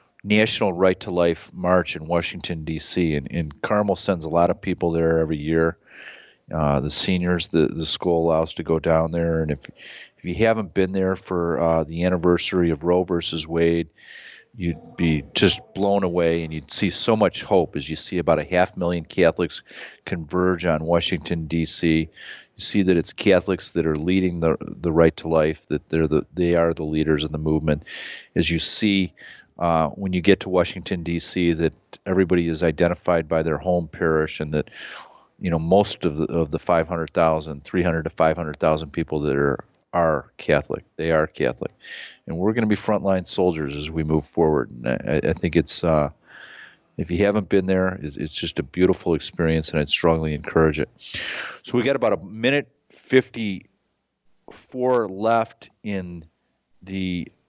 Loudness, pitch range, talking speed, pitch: -22 LUFS, 80-90 Hz, 185 wpm, 85 Hz